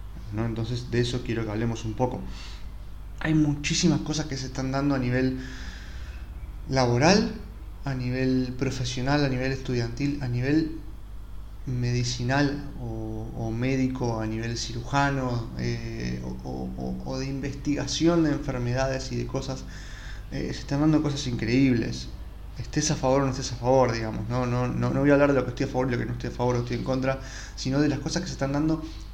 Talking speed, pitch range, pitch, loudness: 190 wpm, 115-140 Hz, 125 Hz, -27 LUFS